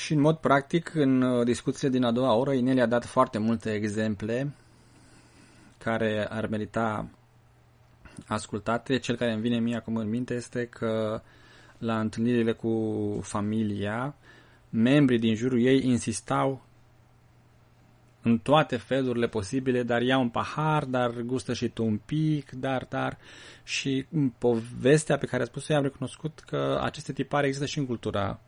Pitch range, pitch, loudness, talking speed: 110-130 Hz, 120 Hz, -27 LUFS, 150 wpm